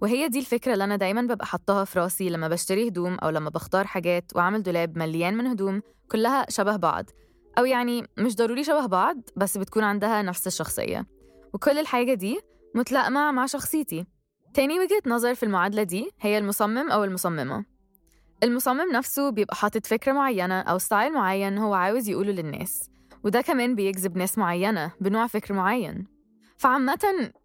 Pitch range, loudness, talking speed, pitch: 185-245 Hz, -25 LUFS, 160 wpm, 210 Hz